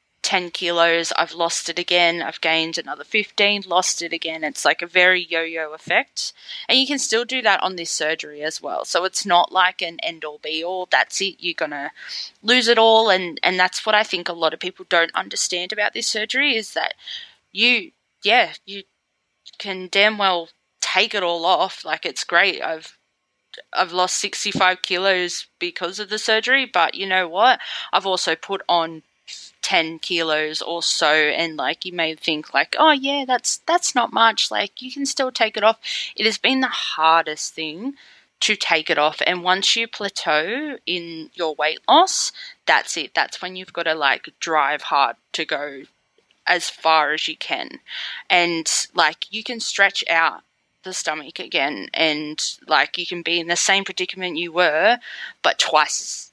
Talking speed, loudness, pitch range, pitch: 185 wpm, -19 LUFS, 165-215 Hz, 180 Hz